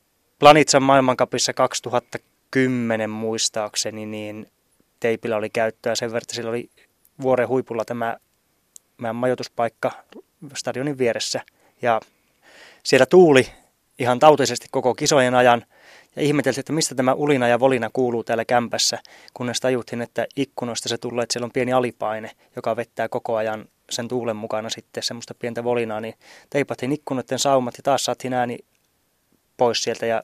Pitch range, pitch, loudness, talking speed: 115-130 Hz, 120 Hz, -21 LUFS, 145 wpm